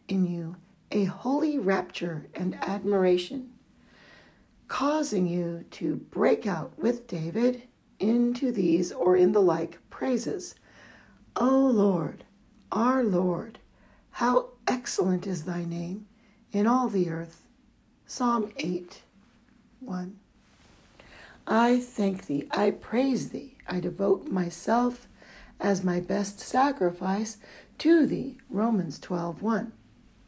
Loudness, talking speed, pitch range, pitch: -27 LUFS, 110 wpm, 180-240 Hz, 205 Hz